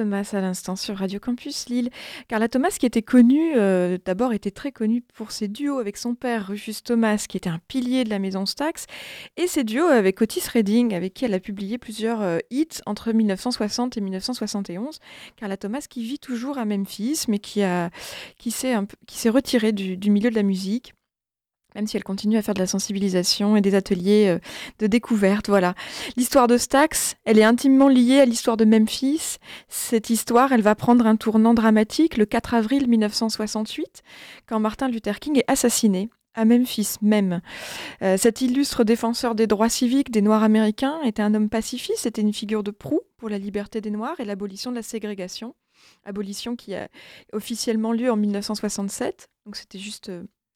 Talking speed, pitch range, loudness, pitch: 190 wpm, 205-245 Hz, -22 LUFS, 225 Hz